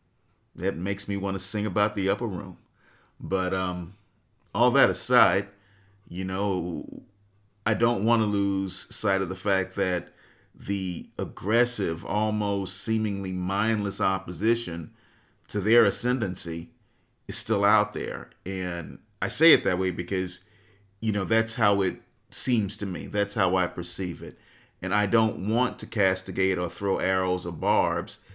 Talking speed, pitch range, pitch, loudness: 150 wpm, 95-110 Hz, 100 Hz, -26 LUFS